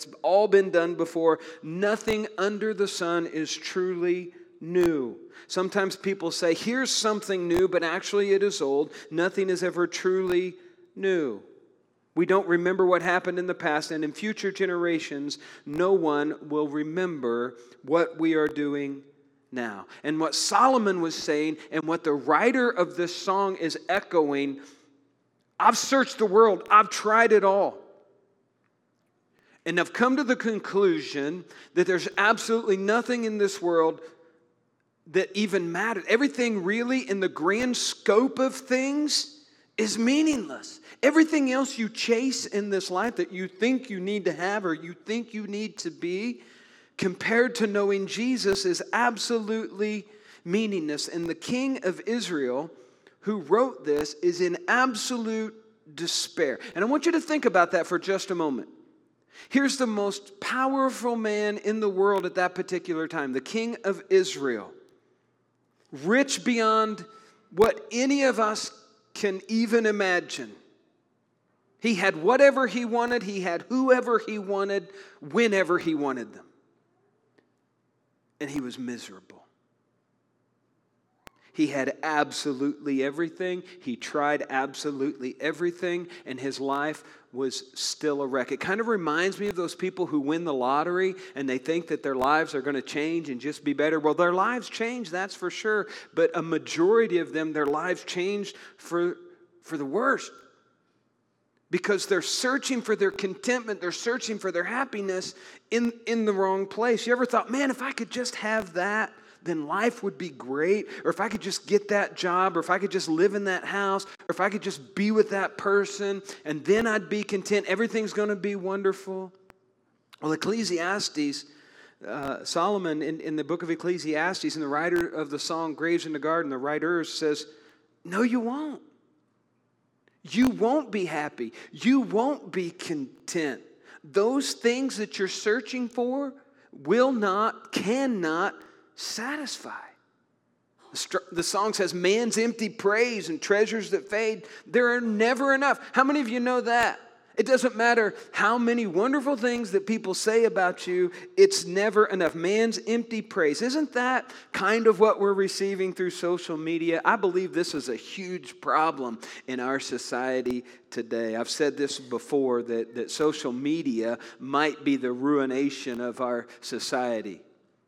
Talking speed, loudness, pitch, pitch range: 155 wpm, -26 LUFS, 195 Hz, 165-225 Hz